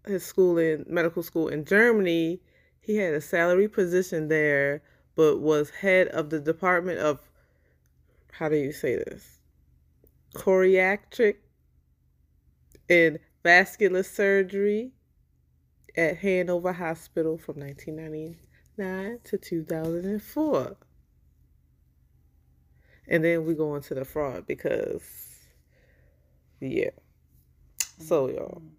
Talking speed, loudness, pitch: 100 wpm, -25 LUFS, 155 Hz